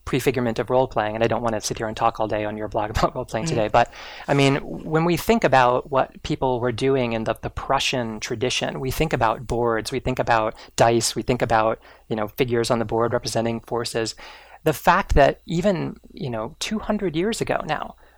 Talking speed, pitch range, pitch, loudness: 220 wpm, 115-135 Hz, 125 Hz, -22 LUFS